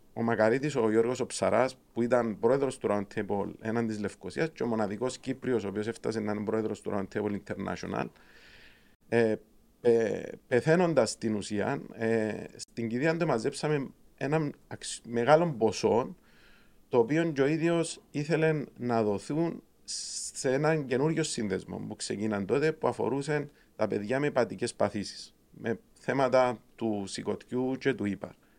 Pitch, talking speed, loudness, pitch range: 120 Hz, 145 wpm, -30 LUFS, 110-145 Hz